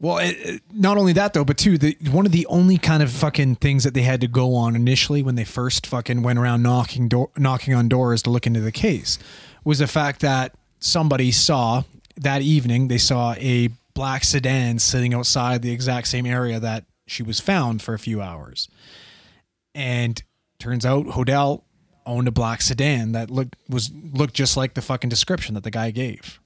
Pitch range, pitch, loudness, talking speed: 120-140 Hz, 125 Hz, -20 LUFS, 200 wpm